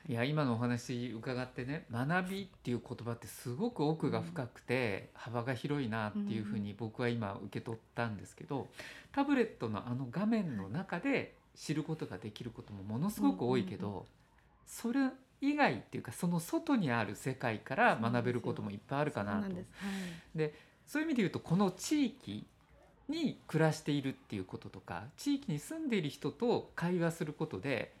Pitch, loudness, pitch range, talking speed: 135 Hz, -37 LUFS, 115-180 Hz, 300 characters per minute